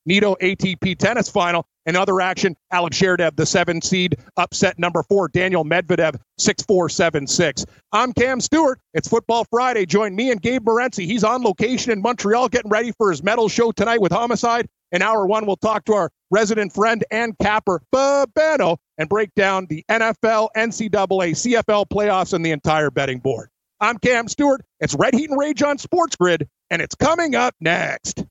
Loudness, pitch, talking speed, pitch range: -19 LUFS, 210 Hz, 180 wpm, 180-230 Hz